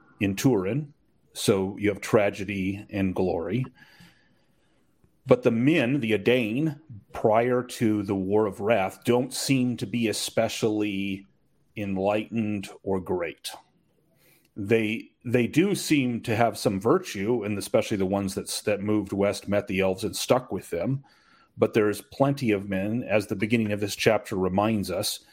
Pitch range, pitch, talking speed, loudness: 100-120 Hz, 105 Hz, 150 wpm, -26 LUFS